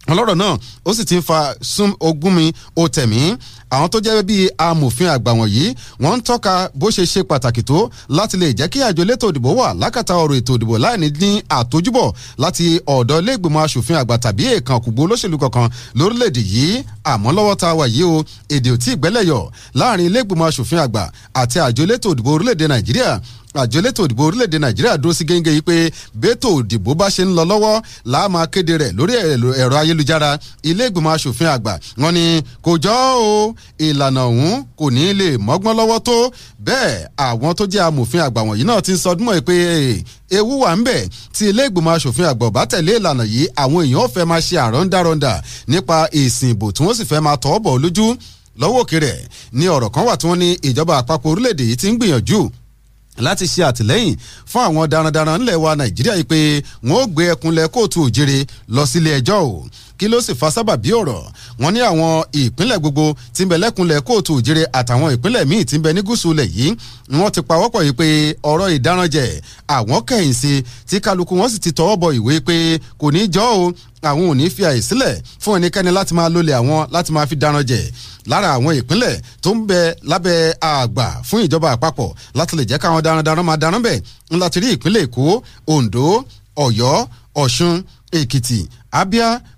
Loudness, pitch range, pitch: -15 LUFS, 125-175 Hz, 155 Hz